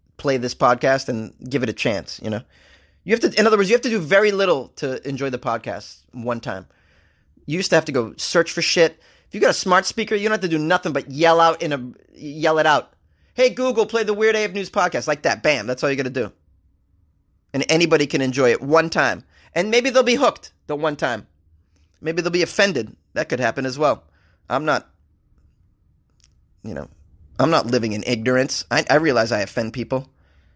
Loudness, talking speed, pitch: -20 LUFS, 220 wpm, 140 Hz